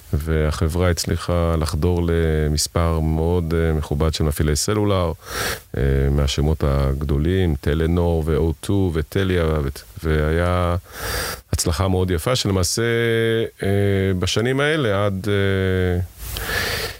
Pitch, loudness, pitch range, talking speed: 85 Hz, -20 LUFS, 80-95 Hz, 80 wpm